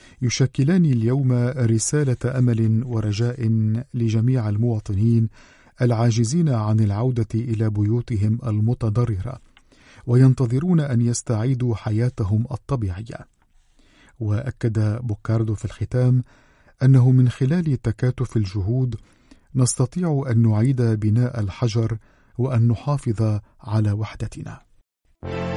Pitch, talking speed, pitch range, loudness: 120 Hz, 85 wpm, 110-125 Hz, -21 LUFS